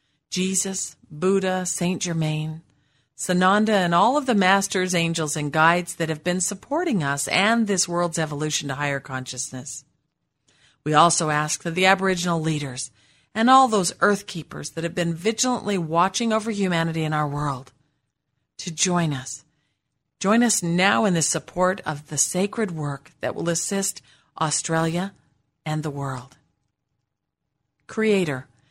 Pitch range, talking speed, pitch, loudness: 145-185 Hz, 140 wpm, 165 Hz, -22 LUFS